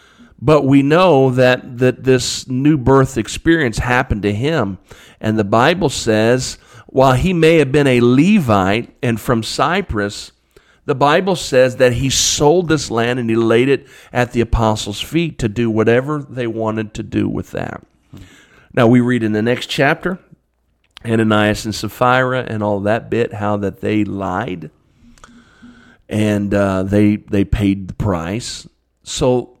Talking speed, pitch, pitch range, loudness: 155 wpm, 120 Hz, 105-130 Hz, -15 LUFS